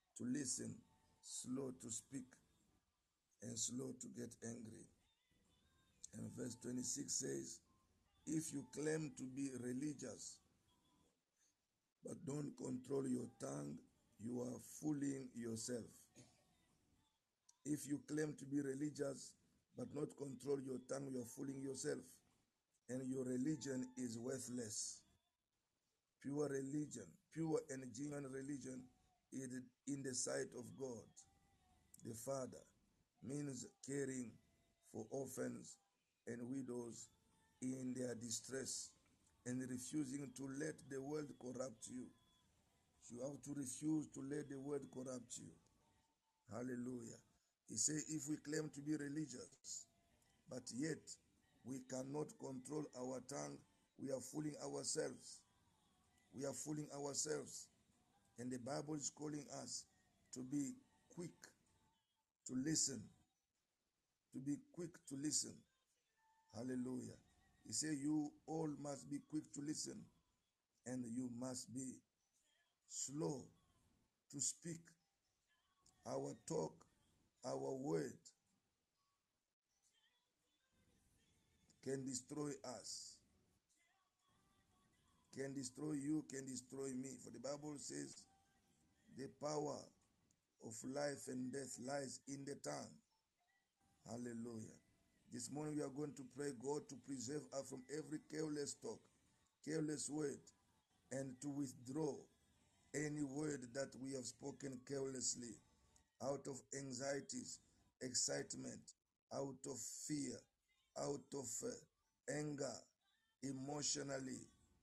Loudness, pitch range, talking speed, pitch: -48 LUFS, 120-145 Hz, 110 wpm, 135 Hz